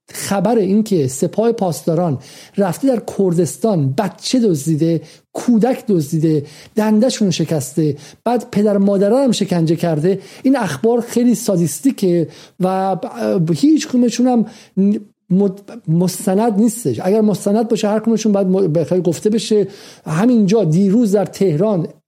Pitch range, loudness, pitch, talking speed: 170-225 Hz, -16 LUFS, 200 Hz, 115 wpm